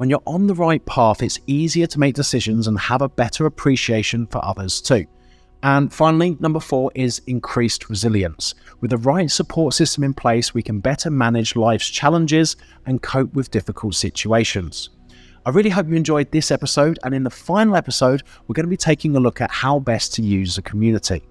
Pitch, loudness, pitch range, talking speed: 130 Hz, -19 LUFS, 115-155 Hz, 195 wpm